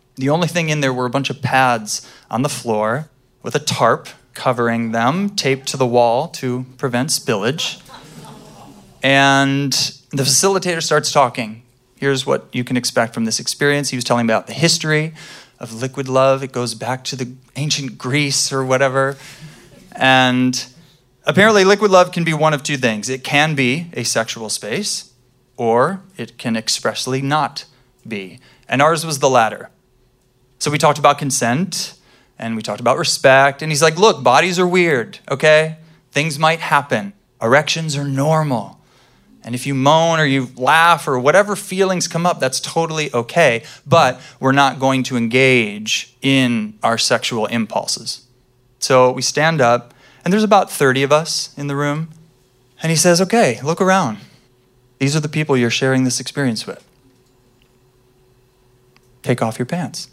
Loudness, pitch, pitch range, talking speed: -16 LUFS, 135 Hz, 125-155 Hz, 165 wpm